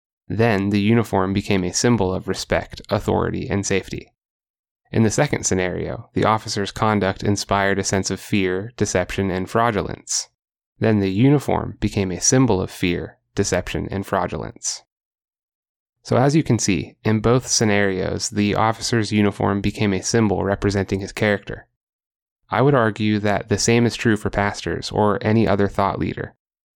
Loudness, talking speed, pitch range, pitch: -20 LUFS, 155 wpm, 95-110 Hz, 100 Hz